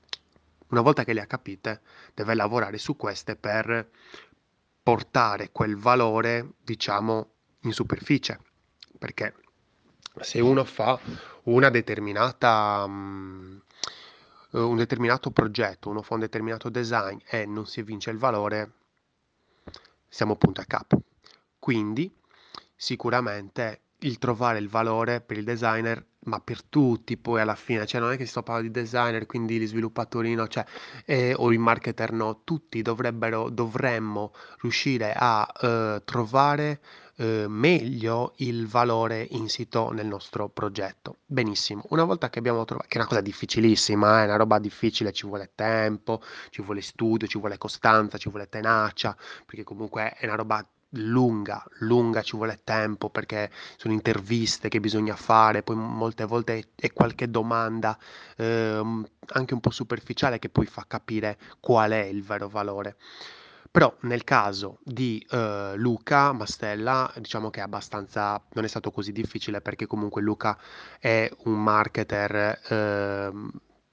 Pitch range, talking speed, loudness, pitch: 105-120 Hz, 145 wpm, -26 LUFS, 110 Hz